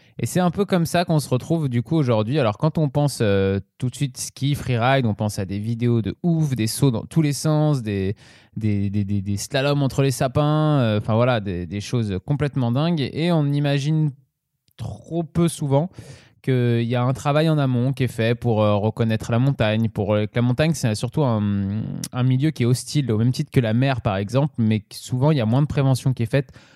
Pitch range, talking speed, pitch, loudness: 115-145 Hz, 230 wpm, 125 Hz, -21 LUFS